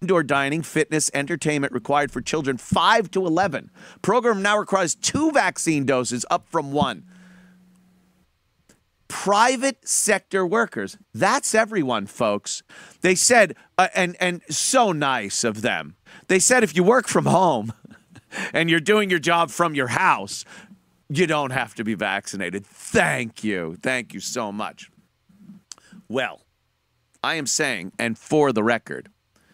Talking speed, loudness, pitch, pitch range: 140 wpm, -21 LUFS, 170 Hz, 140-195 Hz